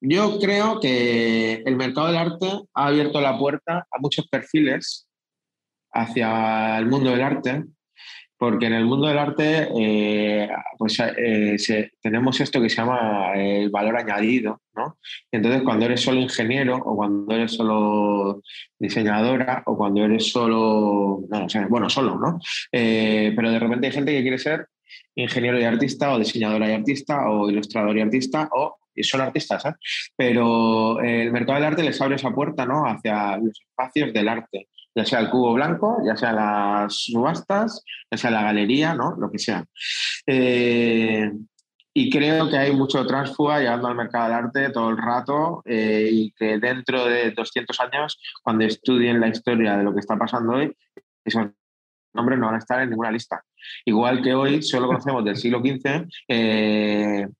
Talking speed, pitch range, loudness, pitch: 170 wpm, 110-135 Hz, -22 LUFS, 120 Hz